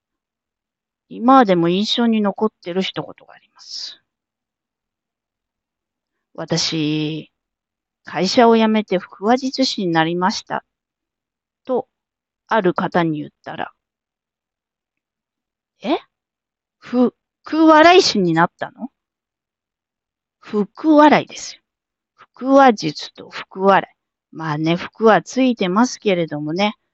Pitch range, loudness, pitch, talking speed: 175-245 Hz, -17 LUFS, 205 Hz, 185 characters per minute